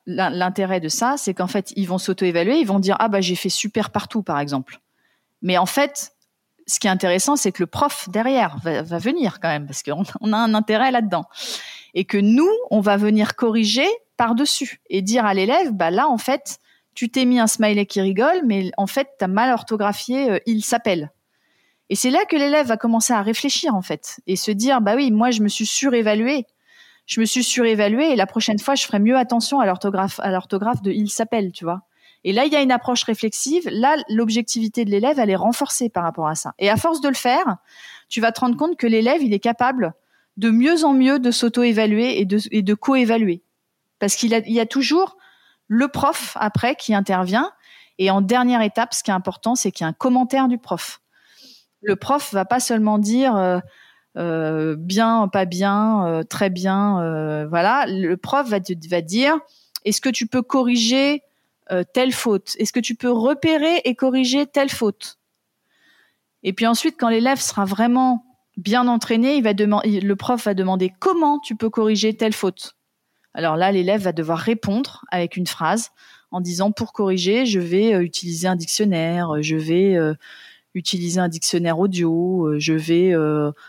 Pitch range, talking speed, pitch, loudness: 190-250 Hz, 205 wpm, 220 Hz, -19 LUFS